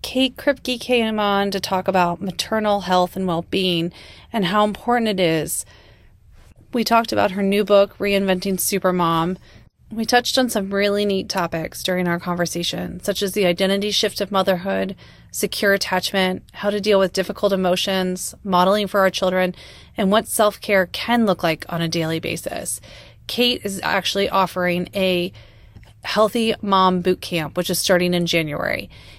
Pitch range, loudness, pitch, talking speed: 175-205 Hz, -20 LUFS, 190 Hz, 160 wpm